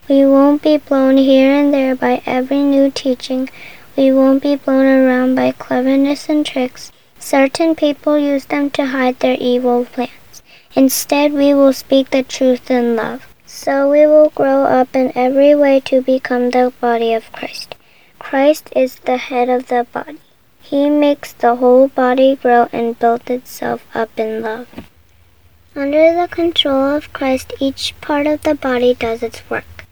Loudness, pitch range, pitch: -14 LUFS, 245-285 Hz, 265 Hz